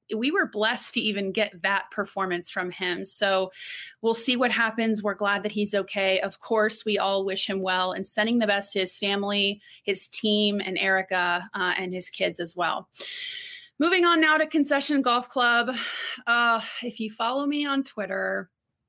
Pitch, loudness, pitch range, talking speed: 210 Hz, -25 LUFS, 190-240 Hz, 185 wpm